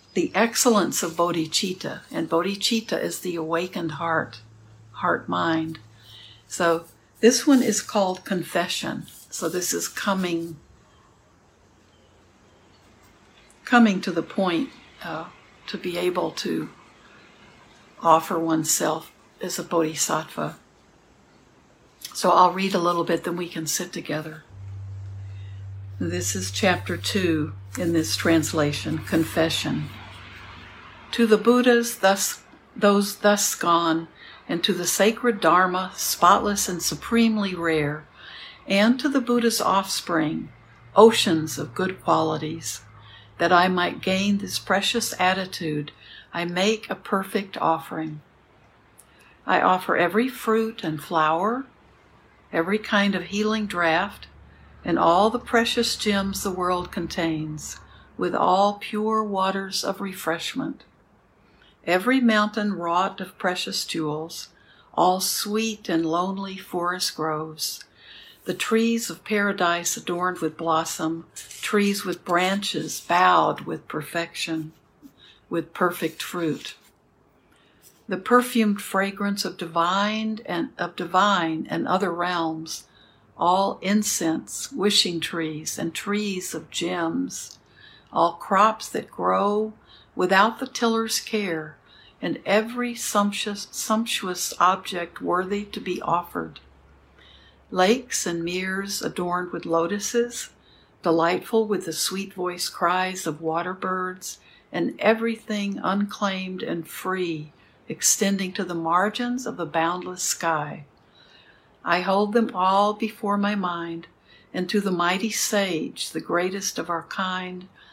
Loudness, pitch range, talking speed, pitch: -23 LUFS, 160-205 Hz, 115 wpm, 180 Hz